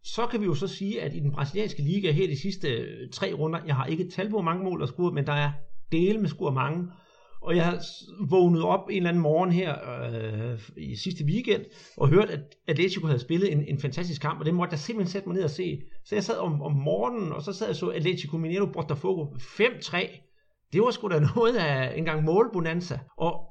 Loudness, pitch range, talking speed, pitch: -27 LUFS, 150-190 Hz, 235 wpm, 170 Hz